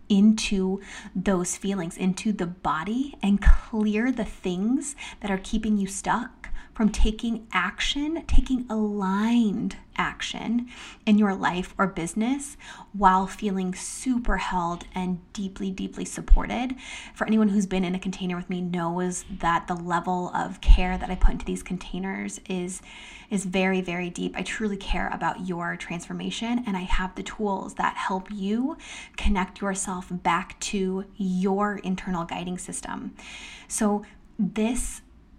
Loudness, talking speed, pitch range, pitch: -27 LUFS, 140 wpm, 185-220 Hz, 195 Hz